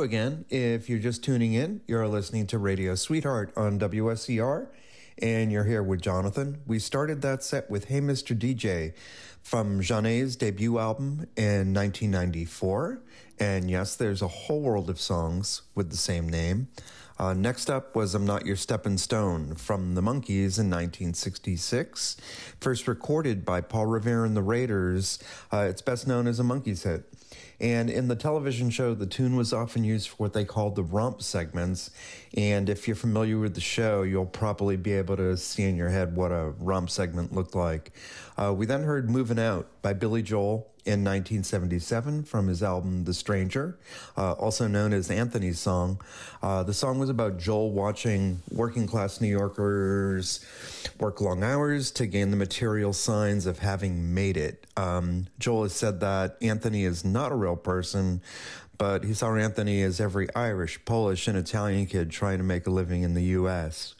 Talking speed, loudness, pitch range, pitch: 175 wpm, -28 LUFS, 95-115 Hz, 105 Hz